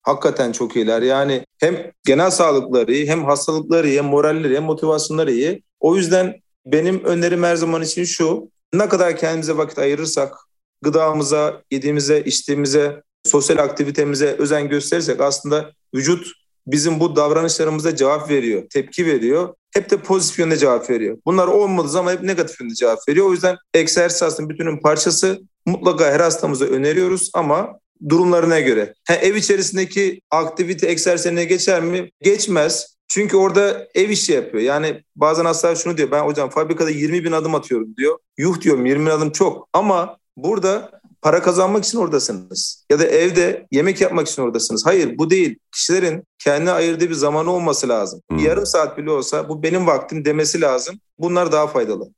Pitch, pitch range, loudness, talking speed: 165 Hz, 150-180 Hz, -17 LUFS, 160 wpm